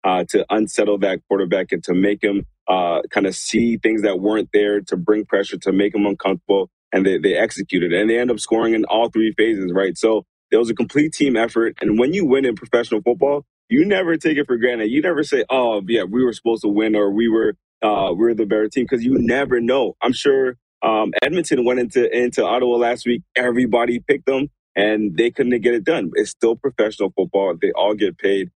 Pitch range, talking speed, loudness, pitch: 105-125 Hz, 225 wpm, -18 LUFS, 115 Hz